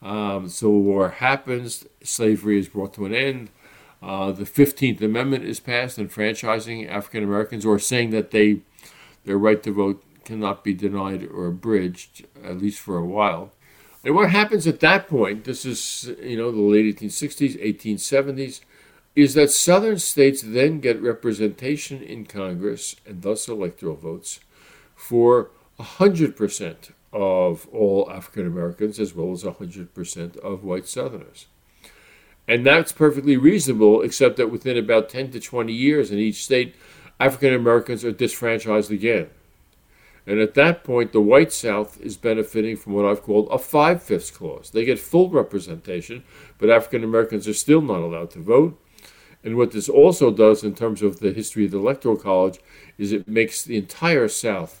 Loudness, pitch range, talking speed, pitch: -20 LUFS, 100-130 Hz, 160 wpm, 110 Hz